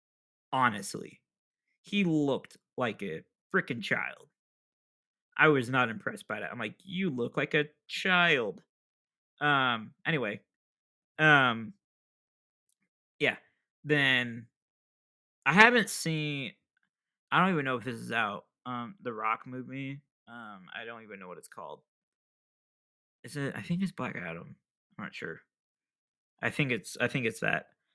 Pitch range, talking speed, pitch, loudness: 125-160 Hz, 140 wpm, 140 Hz, -29 LUFS